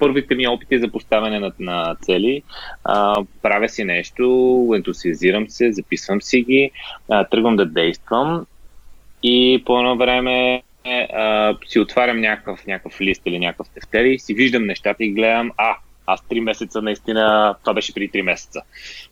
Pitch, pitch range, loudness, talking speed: 115 Hz, 105-125 Hz, -18 LUFS, 155 wpm